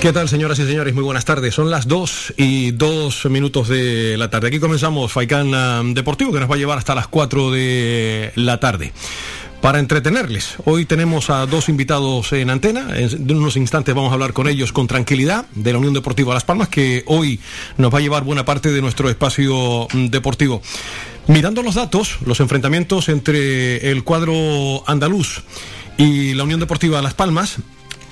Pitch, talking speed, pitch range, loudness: 140 Hz, 180 wpm, 125-155 Hz, -17 LUFS